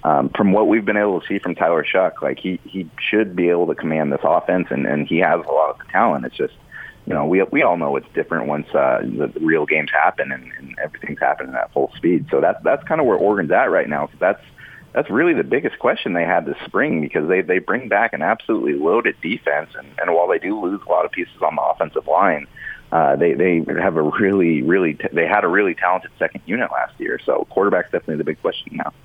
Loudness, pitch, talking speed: -19 LUFS, 315 Hz, 250 wpm